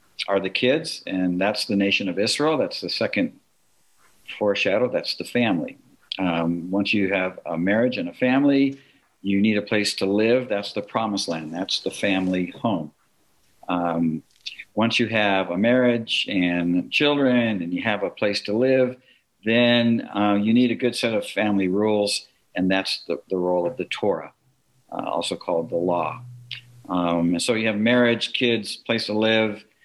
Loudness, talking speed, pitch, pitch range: -22 LUFS, 175 wpm, 105 Hz, 95-120 Hz